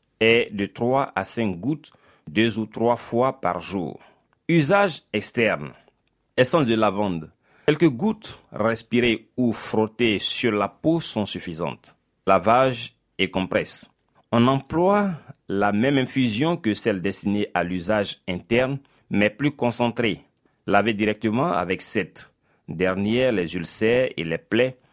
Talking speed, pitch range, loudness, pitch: 130 wpm, 100-130 Hz, -23 LUFS, 115 Hz